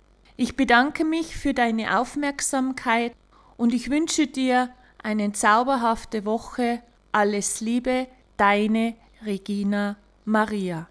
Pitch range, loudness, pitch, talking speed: 210-255 Hz, -23 LUFS, 235 Hz, 100 wpm